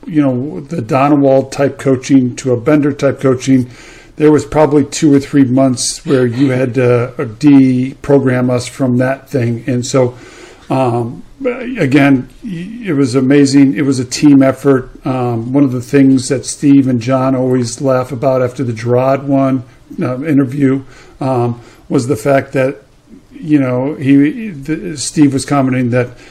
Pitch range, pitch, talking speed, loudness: 130-145 Hz, 135 Hz, 160 wpm, -12 LUFS